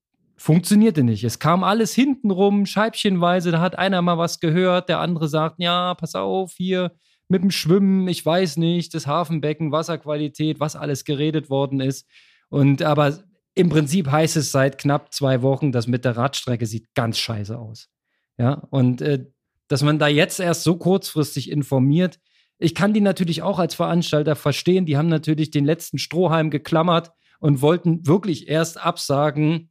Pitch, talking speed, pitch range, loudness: 160 Hz, 165 wpm, 145-180 Hz, -20 LUFS